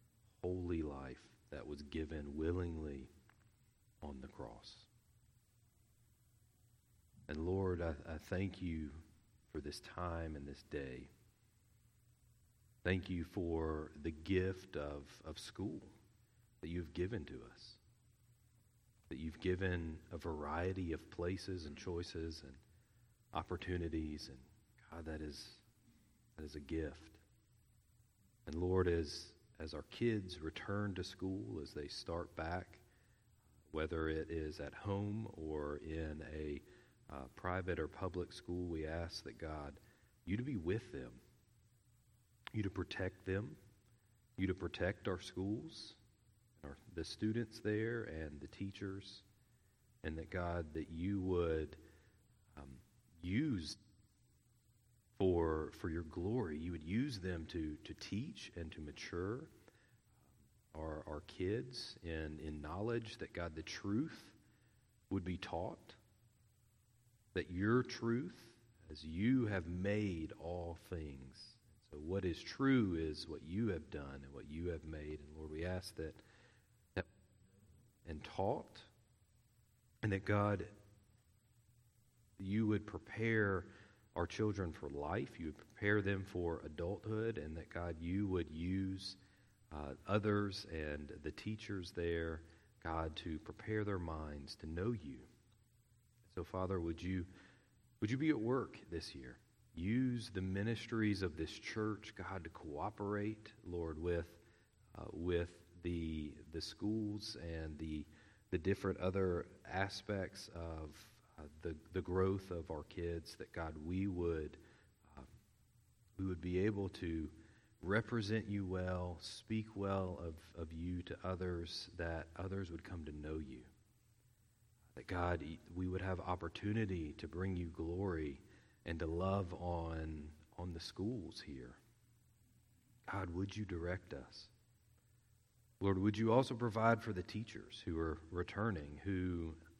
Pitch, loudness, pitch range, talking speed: 95 Hz, -43 LUFS, 80-110 Hz, 130 wpm